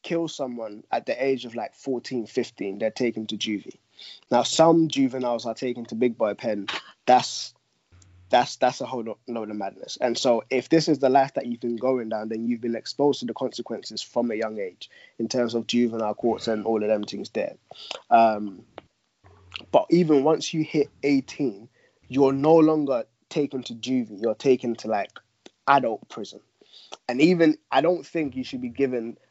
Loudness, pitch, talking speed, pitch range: -24 LUFS, 125 Hz, 190 wpm, 115-140 Hz